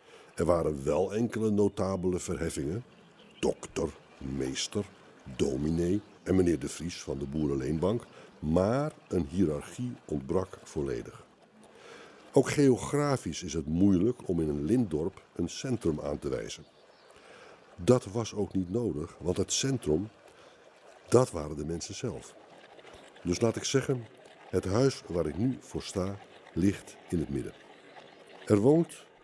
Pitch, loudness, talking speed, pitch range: 95 Hz, -31 LUFS, 135 wpm, 85-120 Hz